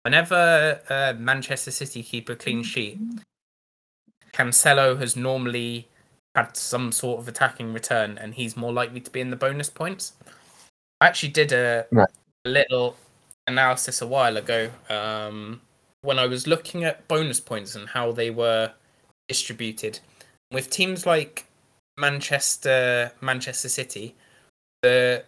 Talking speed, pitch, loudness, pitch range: 135 wpm, 125 Hz, -23 LUFS, 120-140 Hz